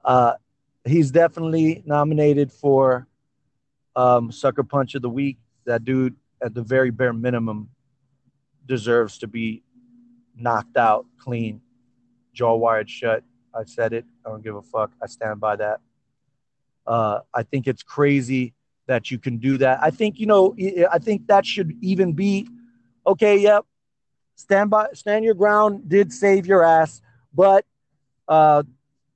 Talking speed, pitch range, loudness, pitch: 150 wpm, 120-165 Hz, -20 LUFS, 135 Hz